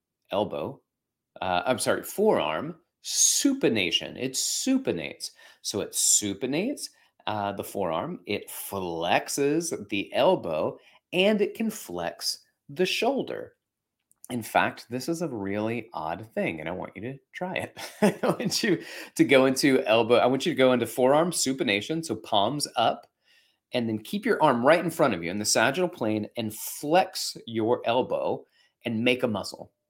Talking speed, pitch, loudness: 160 wpm, 135 Hz, -26 LUFS